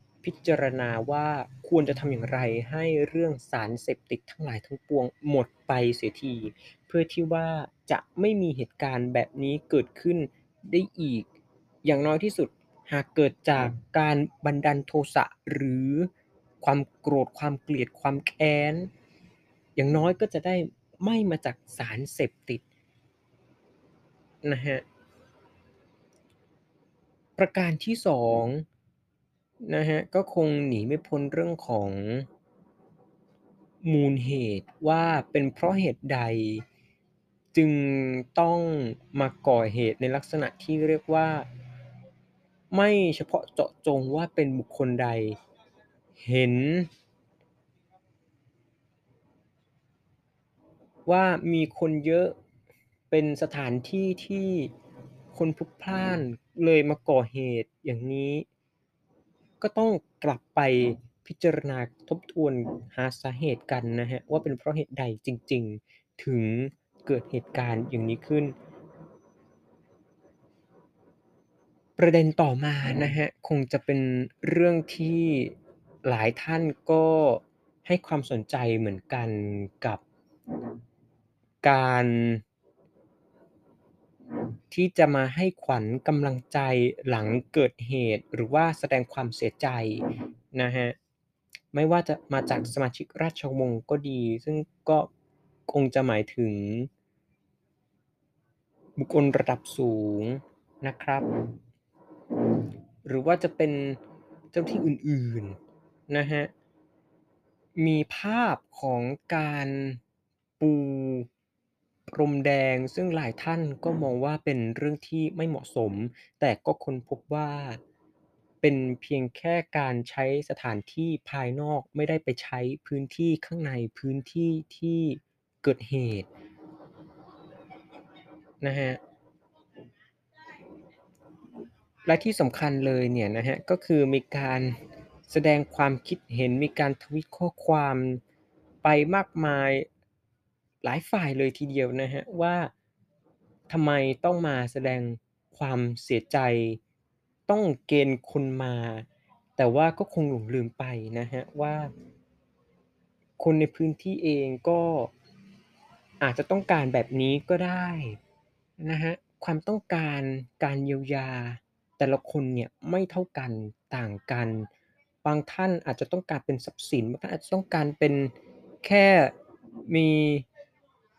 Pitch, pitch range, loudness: 140 Hz, 125-160 Hz, -27 LUFS